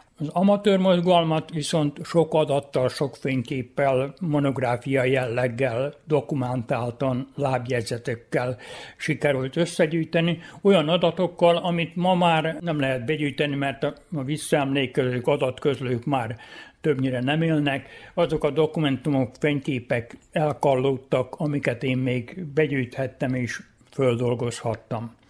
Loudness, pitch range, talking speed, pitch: -24 LUFS, 130-160 Hz, 95 wpm, 140 Hz